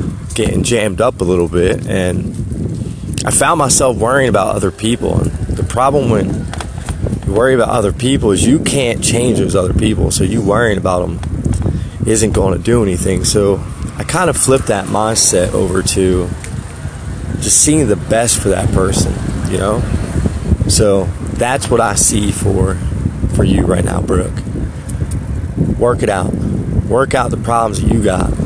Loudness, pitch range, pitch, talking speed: -14 LUFS, 95-115 Hz, 100 Hz, 165 wpm